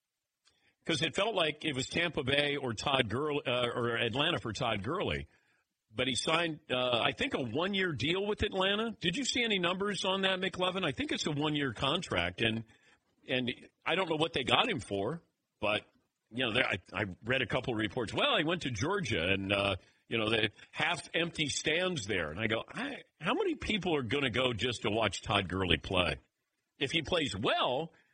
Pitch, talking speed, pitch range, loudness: 135 Hz, 205 wpm, 110-170 Hz, -32 LUFS